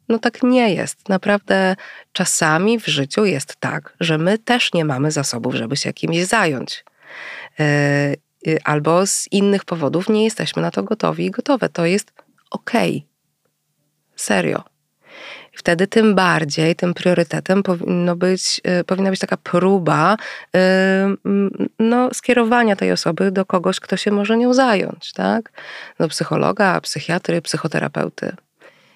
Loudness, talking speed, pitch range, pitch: -18 LUFS, 130 wpm, 160-205 Hz, 185 Hz